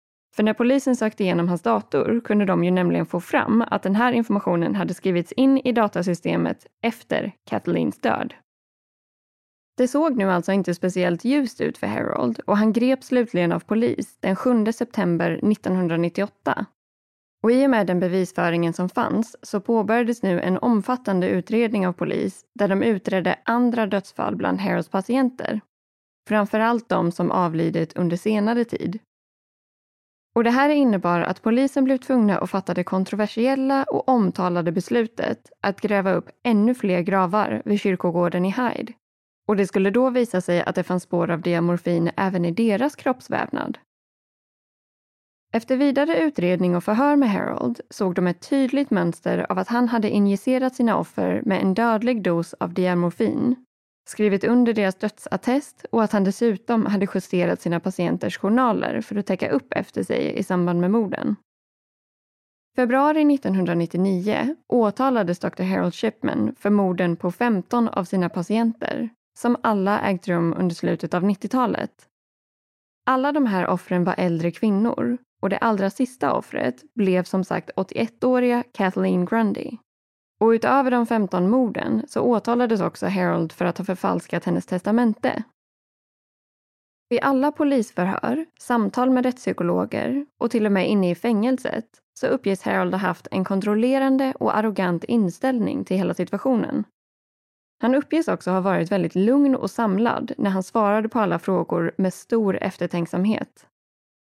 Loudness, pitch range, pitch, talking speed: -22 LUFS, 185-240 Hz, 210 Hz, 150 wpm